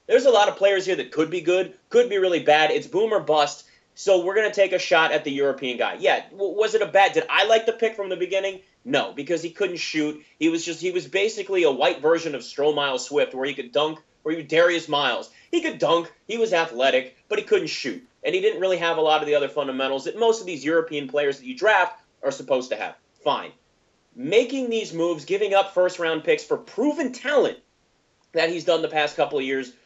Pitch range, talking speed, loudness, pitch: 150-235 Hz, 245 wpm, -22 LUFS, 180 Hz